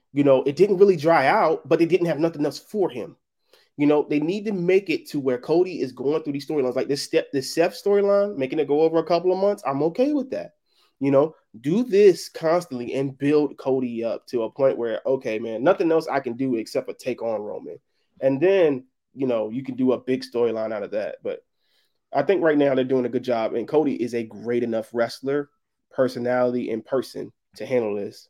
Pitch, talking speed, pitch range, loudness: 145 Hz, 230 wpm, 130-175 Hz, -23 LUFS